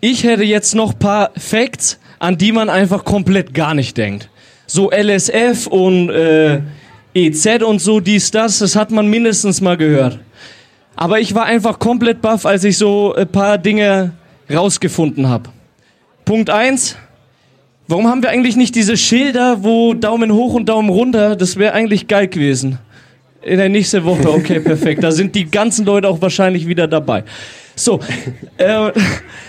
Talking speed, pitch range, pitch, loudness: 165 wpm, 160-220 Hz, 200 Hz, -13 LUFS